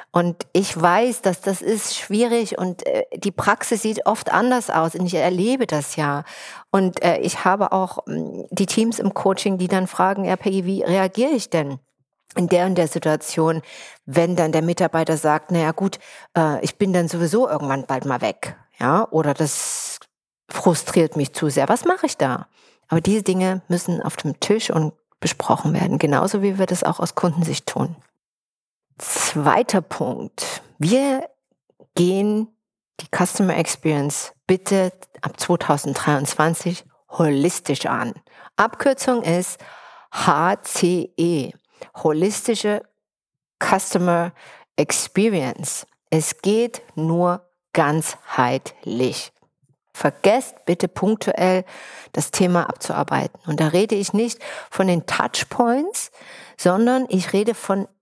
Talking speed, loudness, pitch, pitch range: 130 wpm, -21 LUFS, 185 Hz, 165-205 Hz